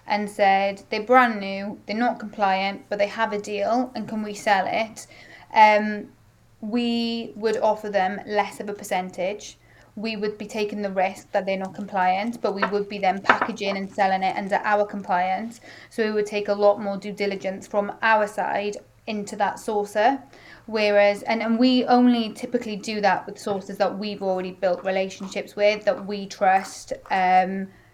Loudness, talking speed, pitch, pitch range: -23 LUFS, 180 wpm, 205 Hz, 195-220 Hz